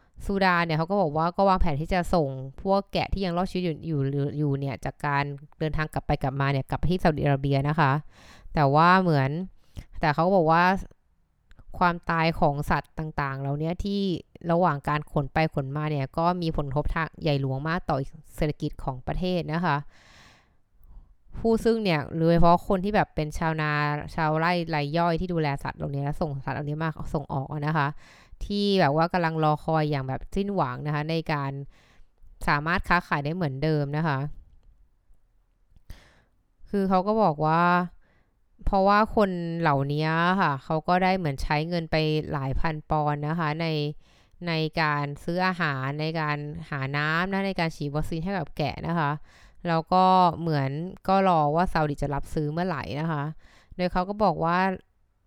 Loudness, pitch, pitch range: -26 LUFS, 155 Hz, 145-175 Hz